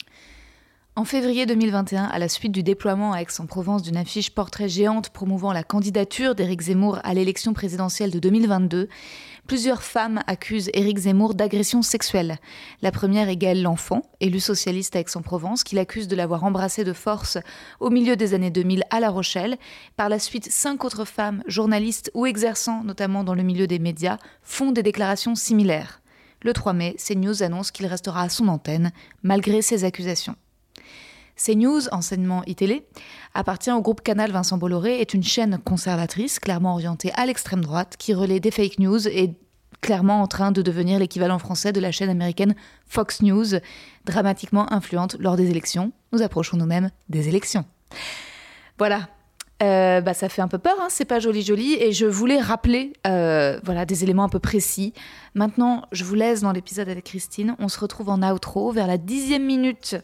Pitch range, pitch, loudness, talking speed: 185-220 Hz, 200 Hz, -22 LUFS, 175 wpm